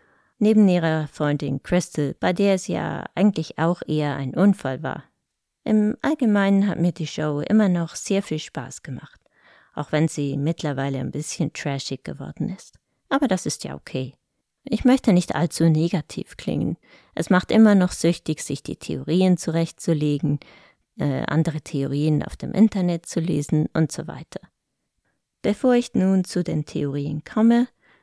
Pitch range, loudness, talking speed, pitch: 150-195 Hz, -22 LUFS, 155 wpm, 165 Hz